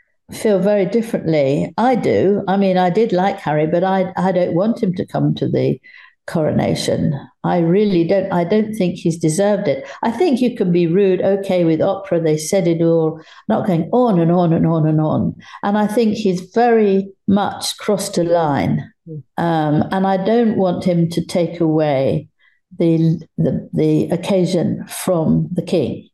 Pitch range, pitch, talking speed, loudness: 165-200 Hz, 180 Hz, 180 wpm, -17 LUFS